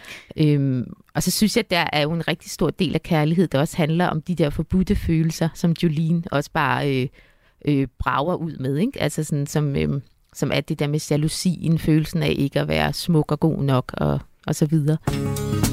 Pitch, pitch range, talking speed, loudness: 155 Hz, 140-165 Hz, 215 wpm, -22 LUFS